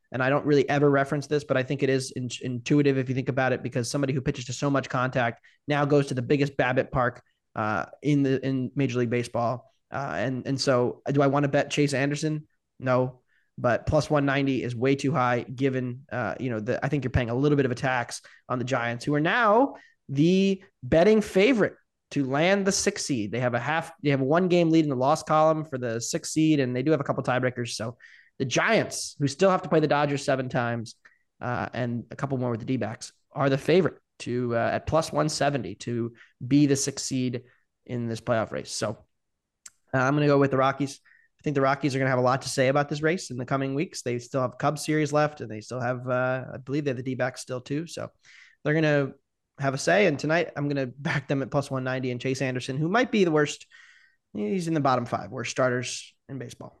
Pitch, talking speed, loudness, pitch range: 135 Hz, 245 wpm, -26 LUFS, 125-150 Hz